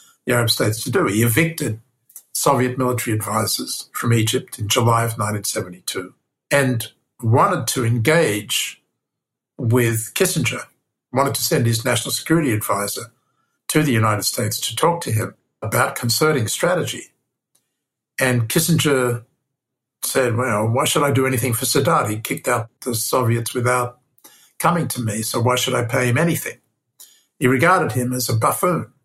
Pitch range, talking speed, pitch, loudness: 115-135 Hz, 150 wpm, 125 Hz, -19 LUFS